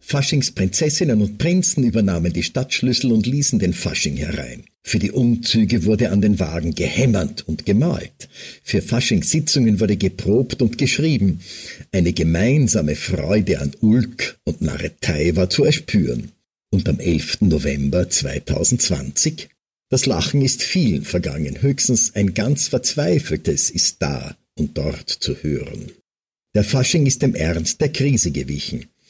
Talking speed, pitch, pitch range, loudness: 135 wpm, 110 Hz, 85-130 Hz, -19 LUFS